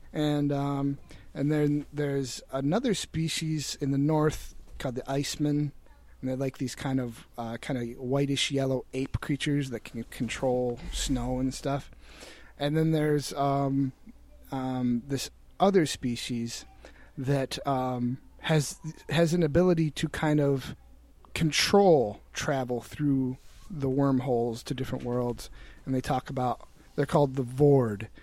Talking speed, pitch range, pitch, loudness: 140 wpm, 130-150 Hz, 140 Hz, -29 LUFS